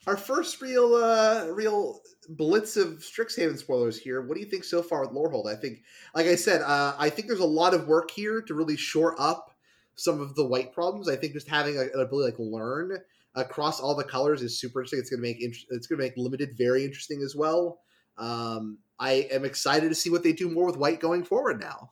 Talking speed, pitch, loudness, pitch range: 240 wpm, 150 Hz, -27 LUFS, 130-175 Hz